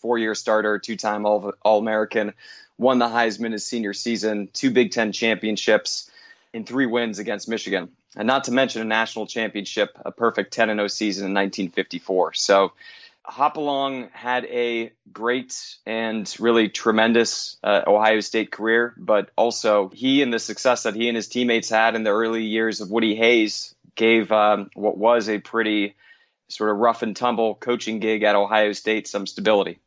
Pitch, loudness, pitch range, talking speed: 110 Hz, -21 LUFS, 105-115 Hz, 175 wpm